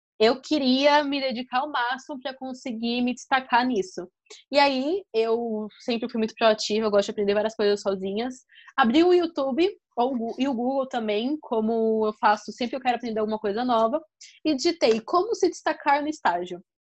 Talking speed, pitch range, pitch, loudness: 175 wpm, 220-285 Hz, 245 Hz, -24 LUFS